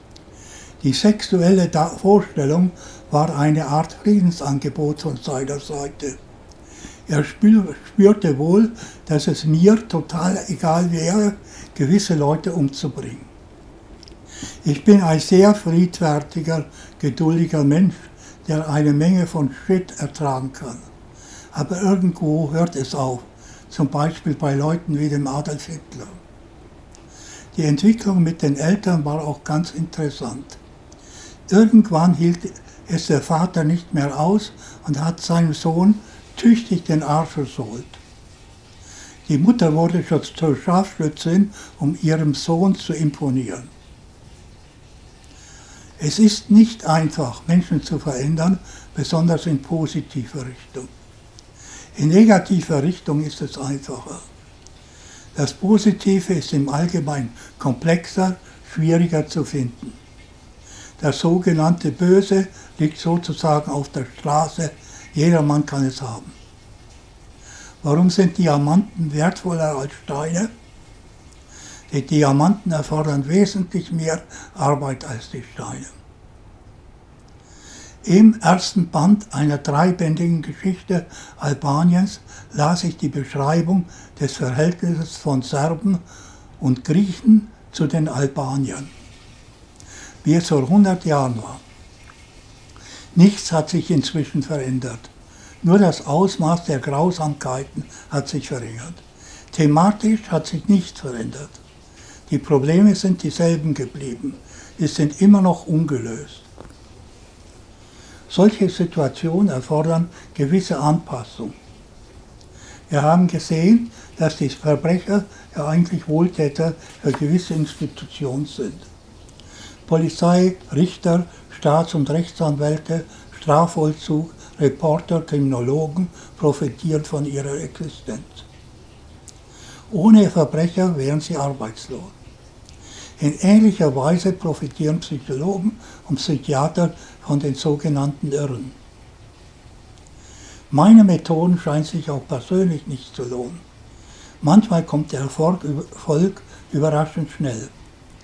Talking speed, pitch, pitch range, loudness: 100 wpm, 155 Hz, 140-175 Hz, -19 LUFS